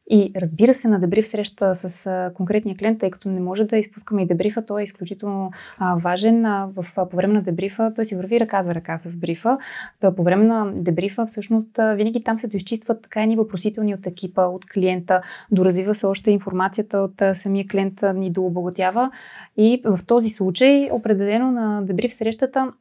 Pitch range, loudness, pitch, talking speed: 185-220 Hz, -21 LUFS, 200 Hz, 175 wpm